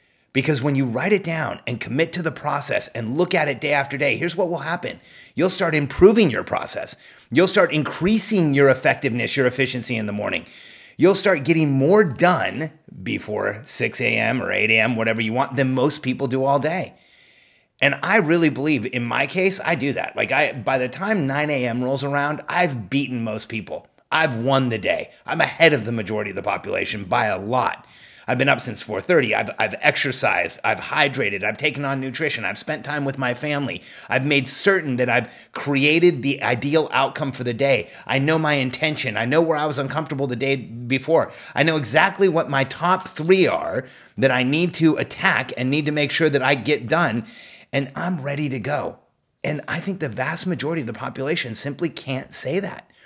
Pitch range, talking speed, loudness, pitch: 130-160 Hz, 205 wpm, -21 LUFS, 145 Hz